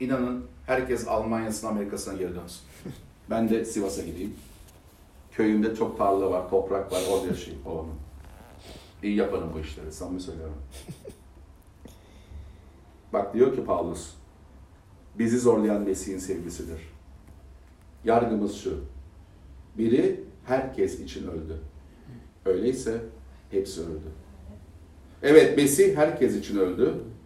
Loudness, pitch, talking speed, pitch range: -26 LUFS, 90 Hz, 105 wpm, 80-110 Hz